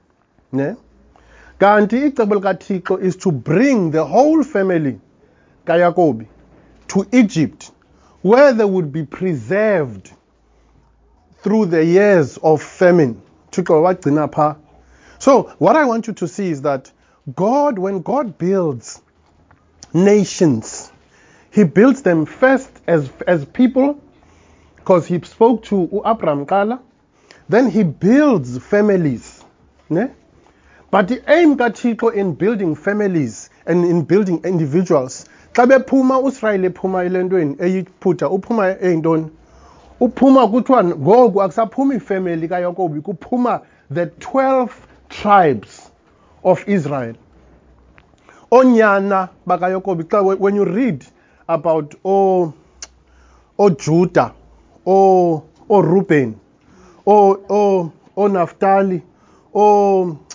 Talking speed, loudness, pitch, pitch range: 95 wpm, -16 LUFS, 185 Hz, 160-210 Hz